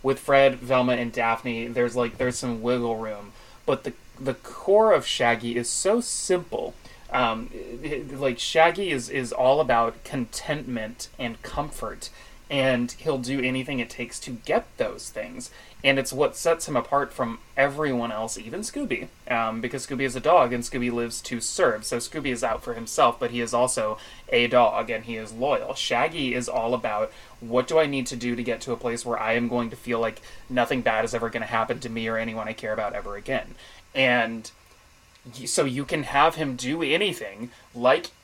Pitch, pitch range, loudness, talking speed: 120 Hz, 115-135 Hz, -25 LUFS, 200 wpm